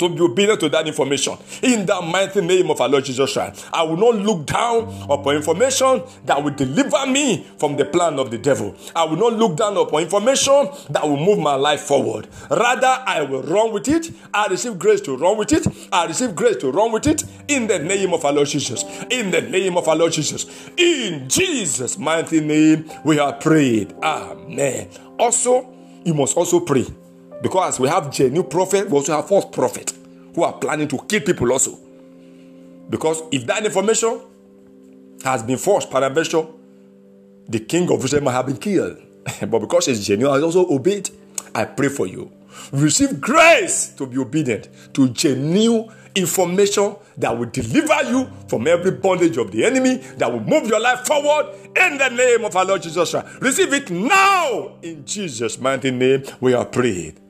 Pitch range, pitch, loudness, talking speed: 135-220 Hz, 165 Hz, -18 LUFS, 185 wpm